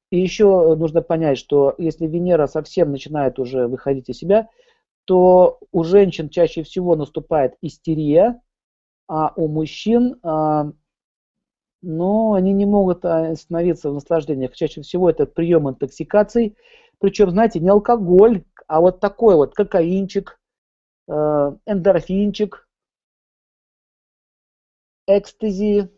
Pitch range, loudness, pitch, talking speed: 155-200 Hz, -18 LUFS, 170 Hz, 105 wpm